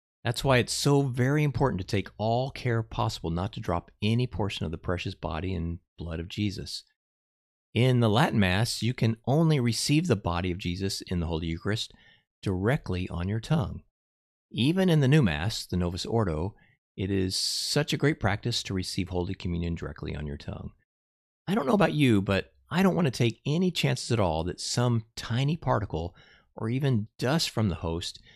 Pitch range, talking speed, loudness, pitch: 90-130 Hz, 195 wpm, -28 LUFS, 110 Hz